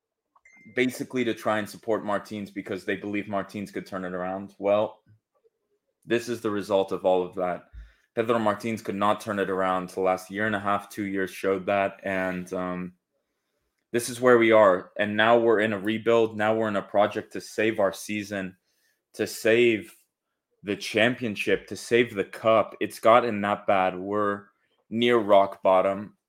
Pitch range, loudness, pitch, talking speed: 95-110 Hz, -25 LUFS, 105 Hz, 180 wpm